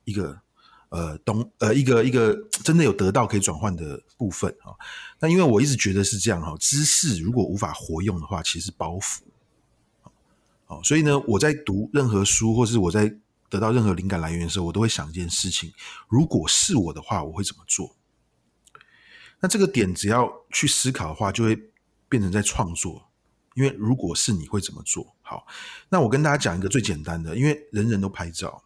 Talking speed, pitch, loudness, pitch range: 295 characters per minute, 105 Hz, -23 LUFS, 95-130 Hz